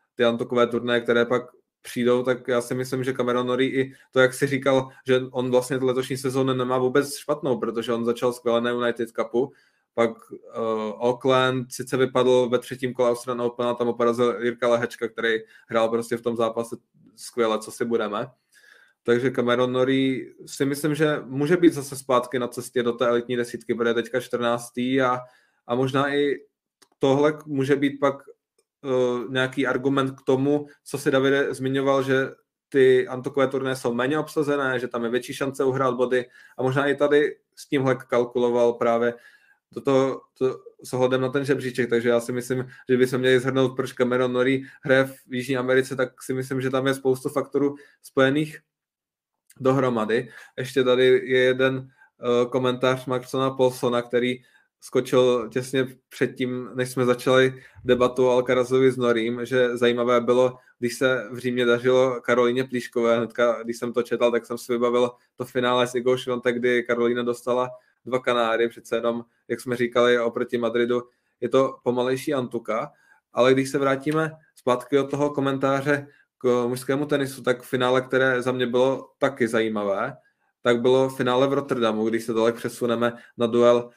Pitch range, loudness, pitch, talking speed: 120-135 Hz, -23 LUFS, 125 Hz, 170 wpm